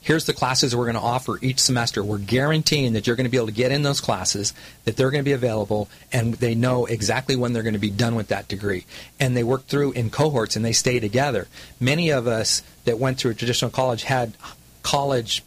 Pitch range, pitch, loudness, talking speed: 110-130 Hz, 125 Hz, -22 LUFS, 240 wpm